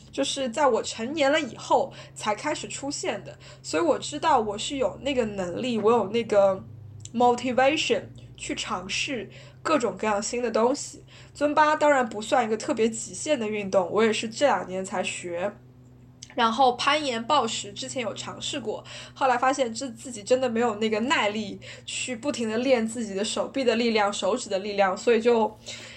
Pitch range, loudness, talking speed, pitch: 205-265 Hz, -25 LUFS, 285 characters per minute, 235 Hz